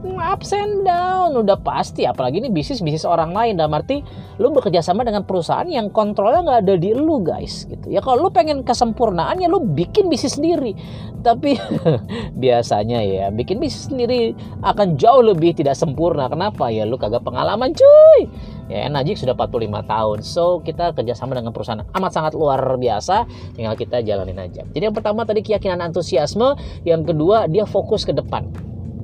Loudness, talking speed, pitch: -18 LUFS, 170 wpm, 175 Hz